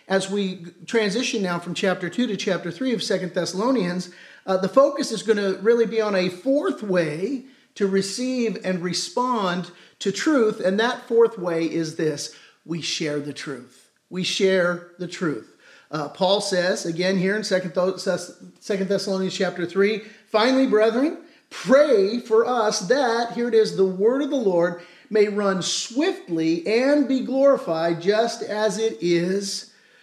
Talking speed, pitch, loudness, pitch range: 160 wpm, 195 Hz, -22 LUFS, 180-230 Hz